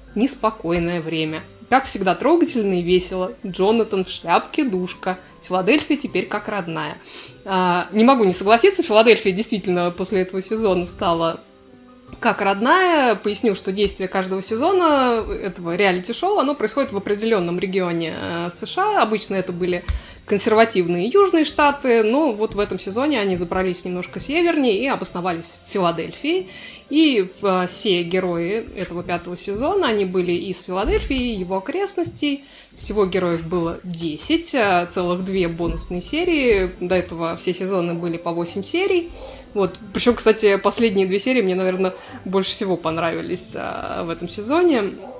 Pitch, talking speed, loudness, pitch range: 195 Hz, 135 wpm, -20 LUFS, 180-240 Hz